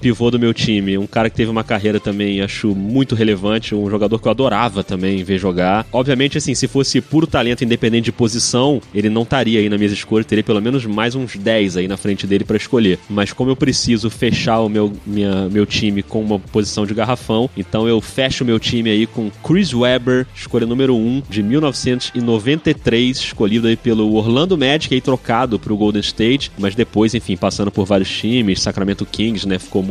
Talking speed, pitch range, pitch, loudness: 205 wpm, 105-125 Hz, 110 Hz, -16 LUFS